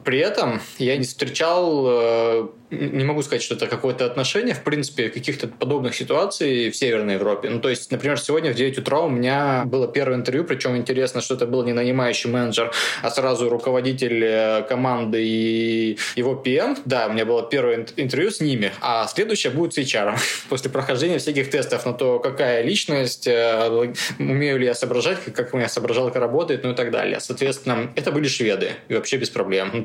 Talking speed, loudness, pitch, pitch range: 185 wpm, -21 LUFS, 130 Hz, 120-140 Hz